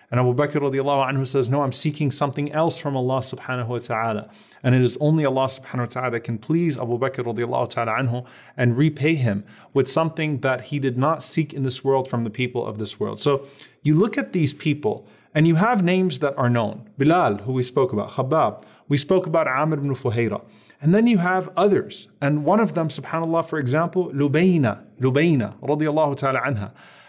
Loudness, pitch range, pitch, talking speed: -22 LUFS, 125-155 Hz, 140 Hz, 195 wpm